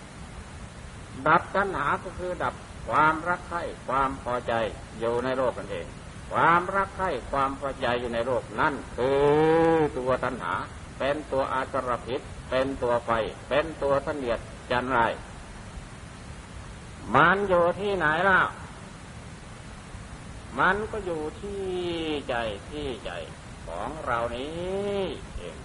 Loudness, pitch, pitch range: -26 LUFS, 140 Hz, 125-175 Hz